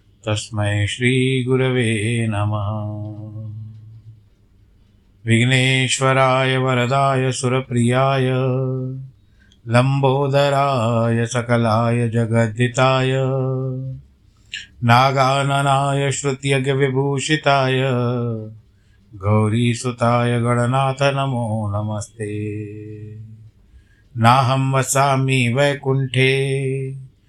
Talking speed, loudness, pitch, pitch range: 40 wpm, -18 LUFS, 120 Hz, 110-135 Hz